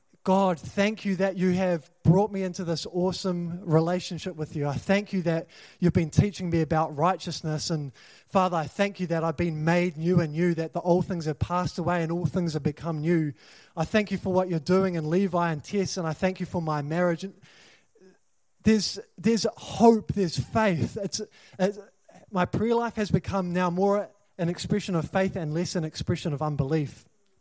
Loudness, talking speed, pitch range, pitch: -27 LUFS, 200 wpm, 165-190 Hz, 180 Hz